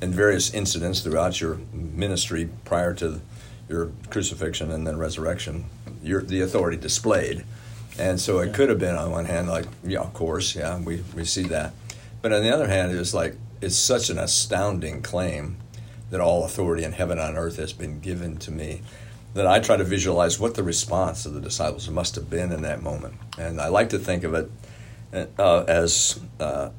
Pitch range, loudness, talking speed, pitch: 85-110 Hz, -24 LUFS, 195 wpm, 90 Hz